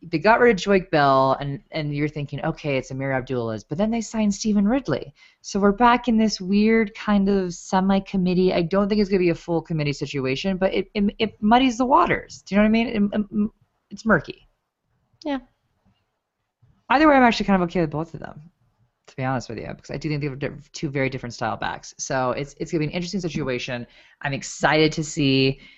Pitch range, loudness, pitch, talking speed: 140-210 Hz, -22 LUFS, 175 Hz, 220 wpm